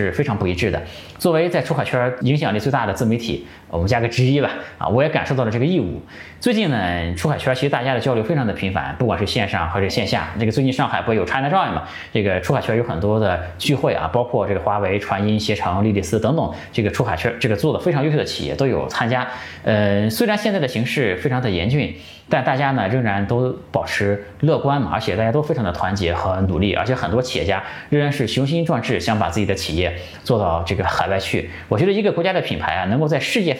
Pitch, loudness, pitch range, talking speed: 110 Hz, -20 LUFS, 100-130 Hz, 385 characters per minute